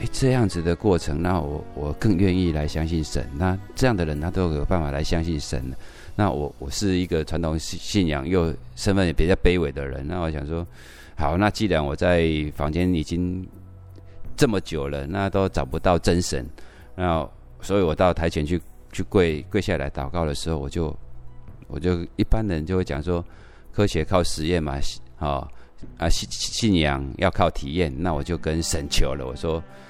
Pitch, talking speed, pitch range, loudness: 85 Hz, 255 characters per minute, 75-90 Hz, -24 LUFS